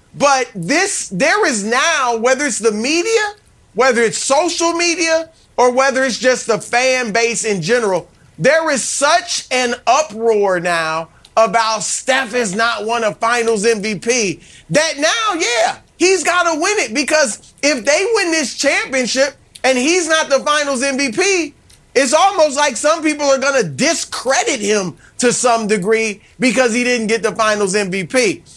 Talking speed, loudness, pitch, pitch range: 160 wpm, -15 LUFS, 255 Hz, 225-310 Hz